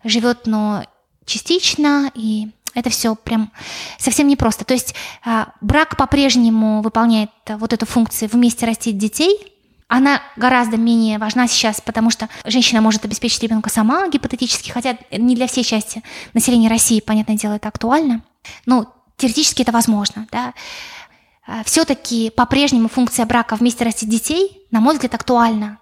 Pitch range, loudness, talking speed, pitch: 220-255 Hz, -16 LUFS, 140 wpm, 235 Hz